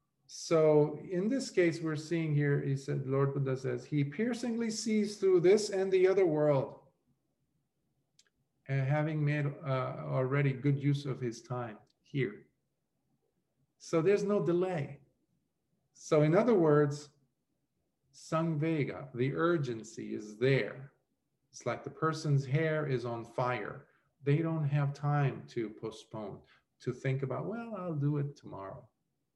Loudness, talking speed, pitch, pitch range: -32 LUFS, 140 wpm, 145 Hz, 135-165 Hz